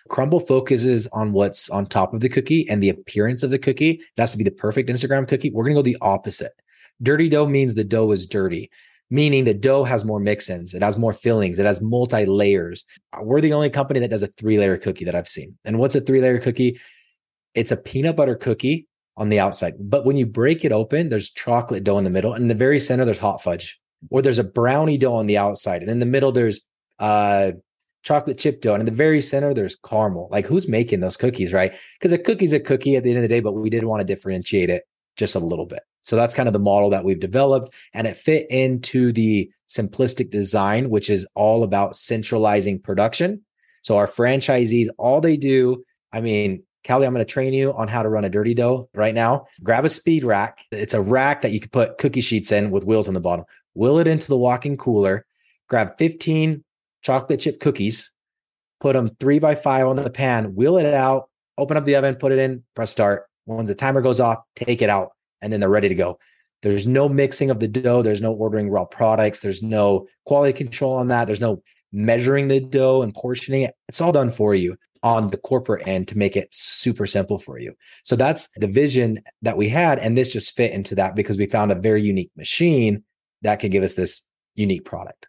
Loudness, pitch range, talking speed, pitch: -20 LUFS, 105-135 Hz, 225 wpm, 115 Hz